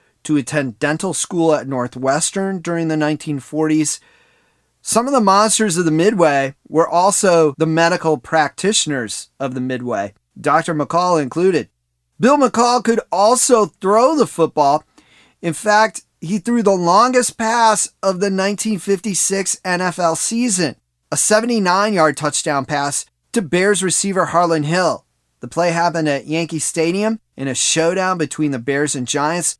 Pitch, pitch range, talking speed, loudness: 170 Hz, 150-205 Hz, 140 wpm, -16 LUFS